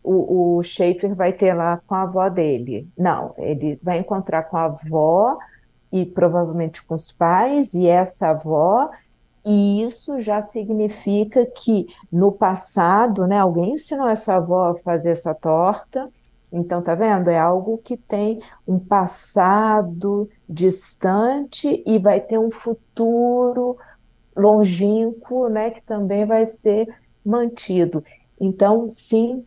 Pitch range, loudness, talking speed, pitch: 175-225 Hz, -19 LUFS, 130 wpm, 200 Hz